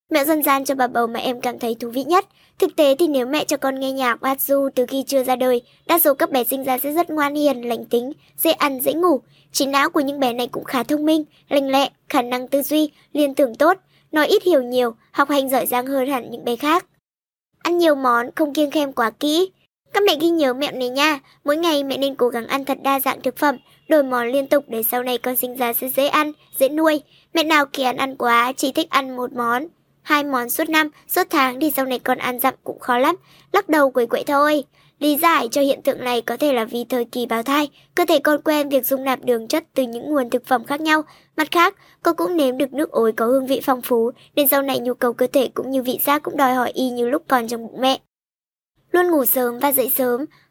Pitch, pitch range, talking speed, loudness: 275 Hz, 250-300 Hz, 260 wpm, -19 LUFS